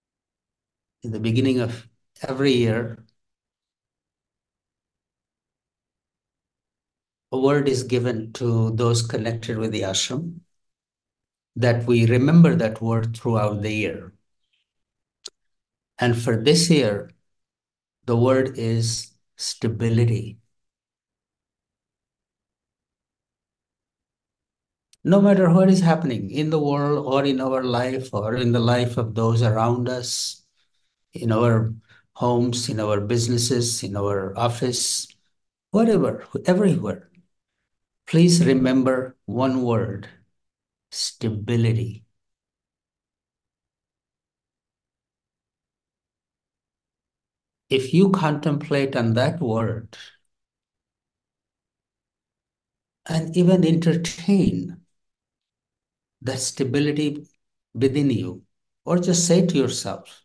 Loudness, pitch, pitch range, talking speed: -21 LUFS, 120 Hz, 110-140 Hz, 85 wpm